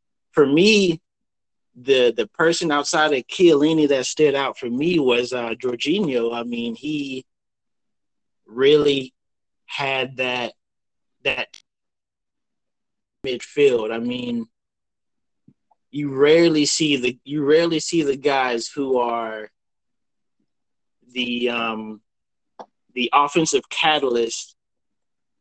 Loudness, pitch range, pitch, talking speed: -20 LUFS, 125-160 Hz, 140 Hz, 100 wpm